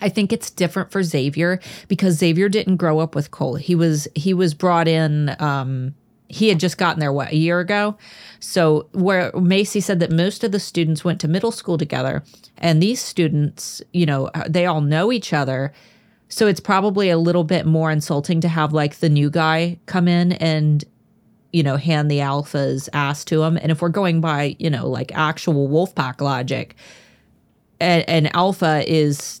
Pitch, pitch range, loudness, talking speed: 165 Hz, 150-180 Hz, -19 LUFS, 190 wpm